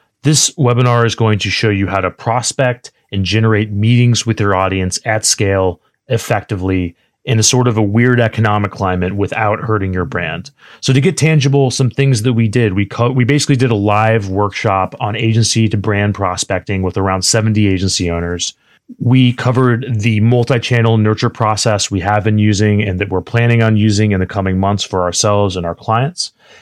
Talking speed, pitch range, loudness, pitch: 185 wpm, 100-120 Hz, -14 LUFS, 110 Hz